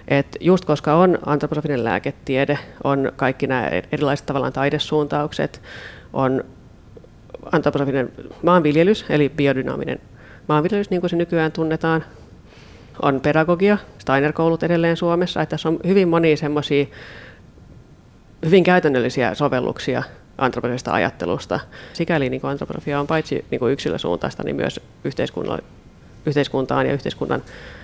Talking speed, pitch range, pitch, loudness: 110 wpm, 140-165 Hz, 150 Hz, -20 LUFS